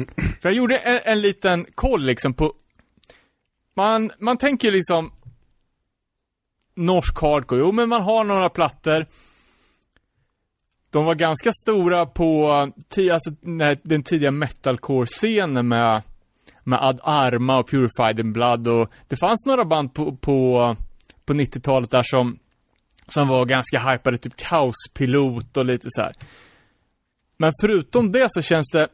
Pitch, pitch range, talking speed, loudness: 150 Hz, 130-175 Hz, 135 wpm, -20 LUFS